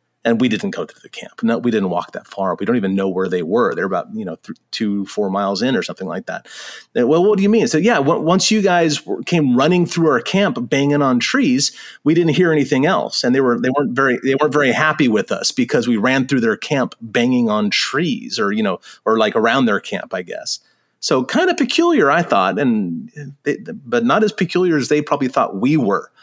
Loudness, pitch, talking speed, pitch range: -17 LUFS, 175 Hz, 245 wpm, 140-230 Hz